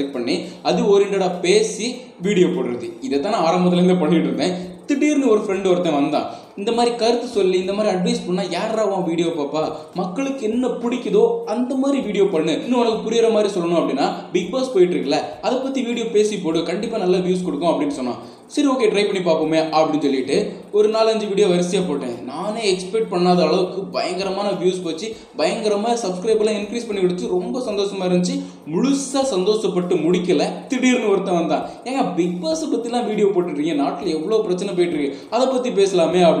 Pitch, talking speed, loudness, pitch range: 200 Hz, 170 wpm, -20 LUFS, 180-230 Hz